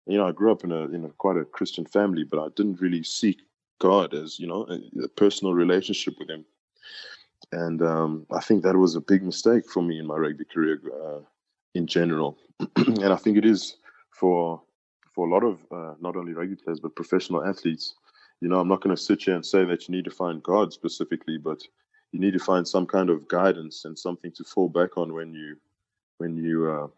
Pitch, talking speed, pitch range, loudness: 90 Hz, 225 wpm, 80-95 Hz, -25 LUFS